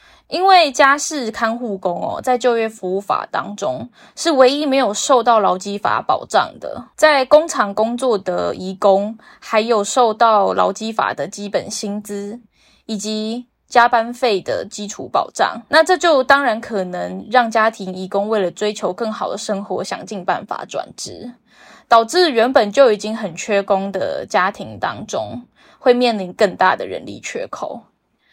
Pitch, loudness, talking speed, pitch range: 225 Hz, -17 LUFS, 235 characters per minute, 205-255 Hz